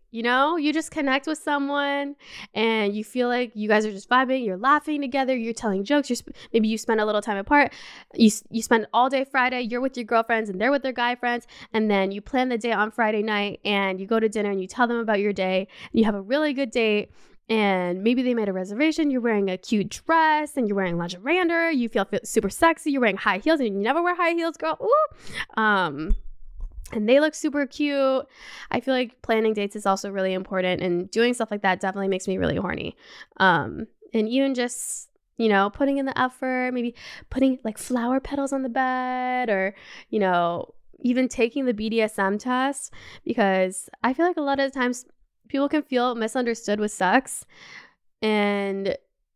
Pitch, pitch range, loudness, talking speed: 240 Hz, 210-270 Hz, -24 LUFS, 210 wpm